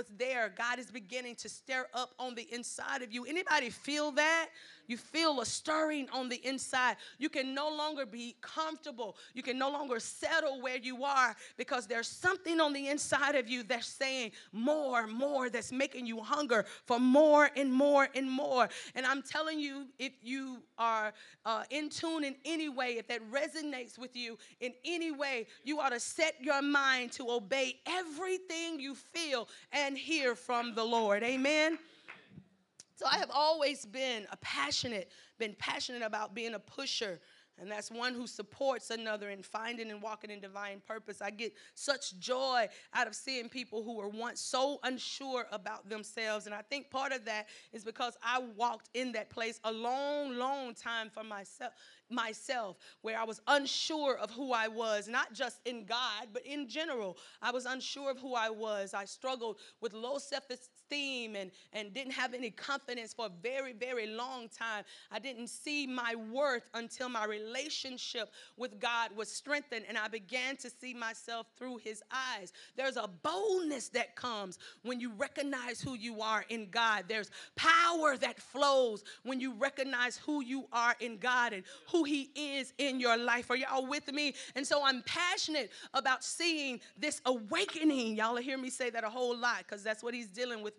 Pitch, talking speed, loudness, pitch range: 250 Hz, 180 wpm, -35 LUFS, 230-275 Hz